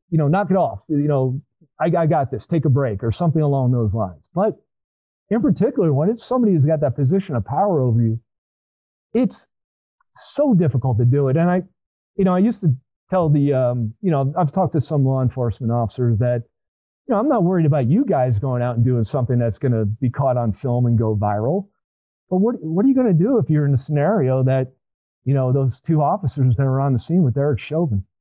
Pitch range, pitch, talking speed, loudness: 120-165 Hz, 135 Hz, 230 wpm, -19 LUFS